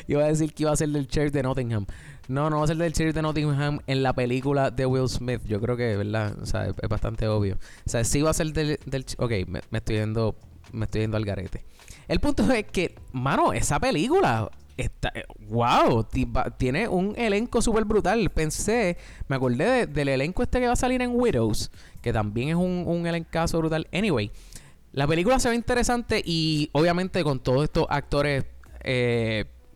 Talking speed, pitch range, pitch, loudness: 205 wpm, 110-165 Hz, 135 Hz, -25 LUFS